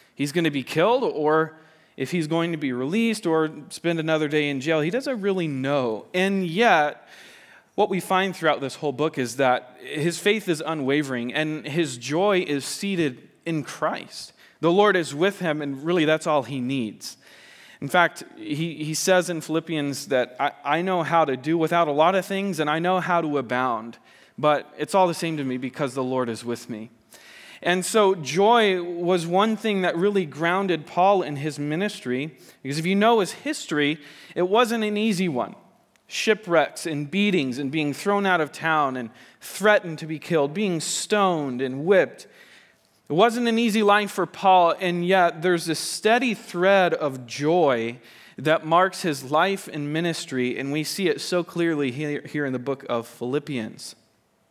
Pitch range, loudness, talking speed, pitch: 145-185 Hz, -23 LUFS, 185 wpm, 160 Hz